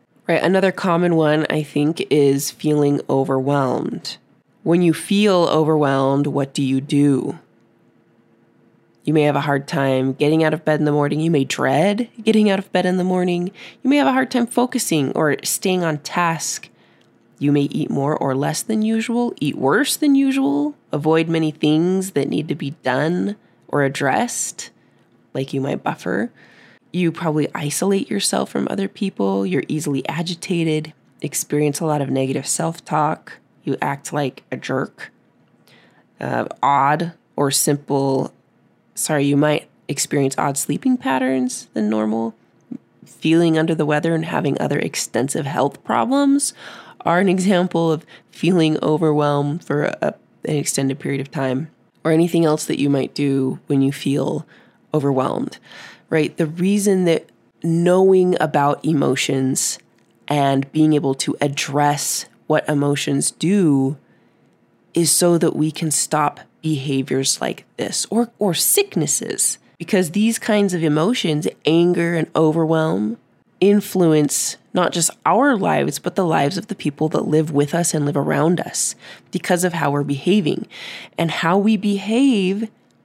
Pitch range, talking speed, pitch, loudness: 140-180 Hz, 150 wpm, 155 Hz, -19 LUFS